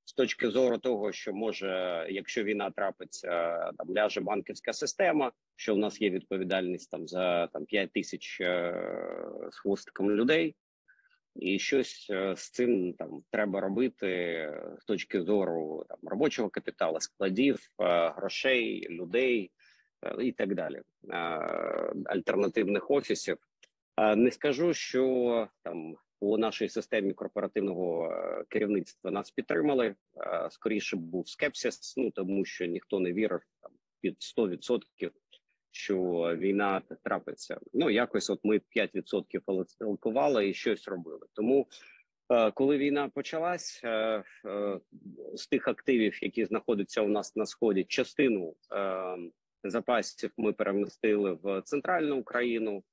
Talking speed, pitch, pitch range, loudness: 120 wpm, 100 Hz, 95-125 Hz, -31 LUFS